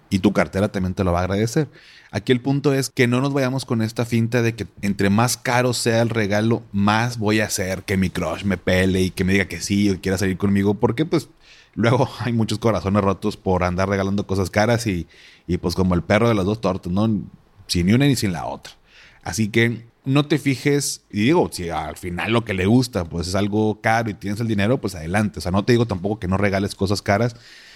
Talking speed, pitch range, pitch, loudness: 240 wpm, 95-115 Hz, 105 Hz, -21 LUFS